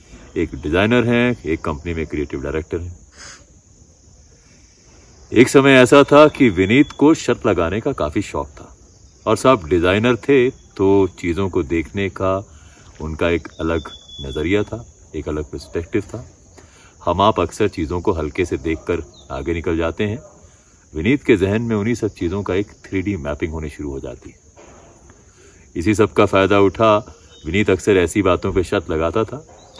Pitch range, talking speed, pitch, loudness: 80-110 Hz, 160 wpm, 95 Hz, -18 LUFS